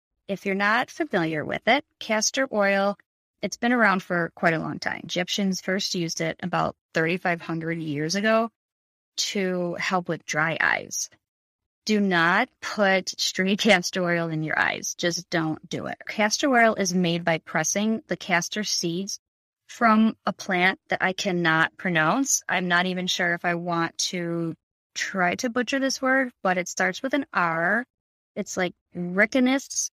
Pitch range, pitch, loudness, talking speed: 170-215 Hz, 185 Hz, -24 LUFS, 160 wpm